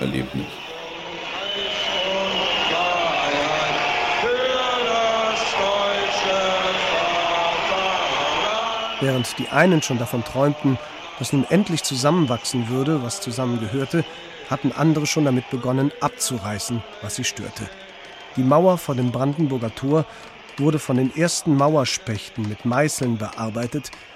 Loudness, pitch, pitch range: -21 LUFS, 145 Hz, 125-170 Hz